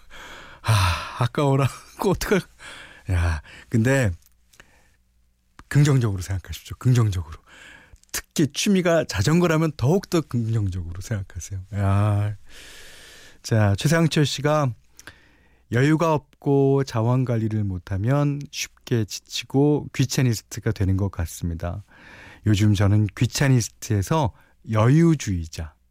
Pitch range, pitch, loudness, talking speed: 95-140 Hz, 110 Hz, -22 LUFS, 245 characters per minute